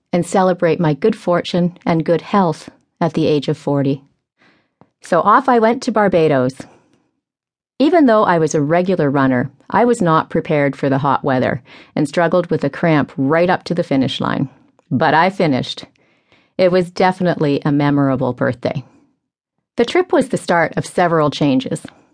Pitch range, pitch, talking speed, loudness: 145-185 Hz, 165 Hz, 170 wpm, -16 LUFS